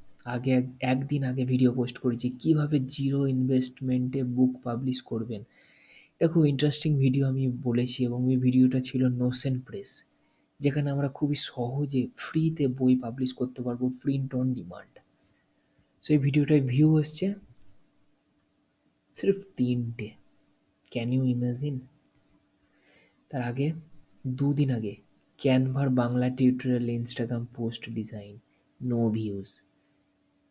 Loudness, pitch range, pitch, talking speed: -28 LUFS, 120-140 Hz, 130 Hz, 115 wpm